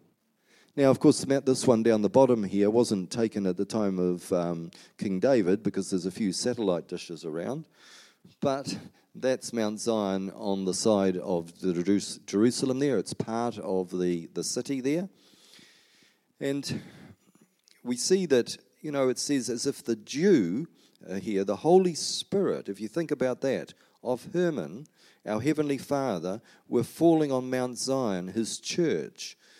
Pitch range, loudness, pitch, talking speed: 100-140 Hz, -28 LUFS, 120 Hz, 155 wpm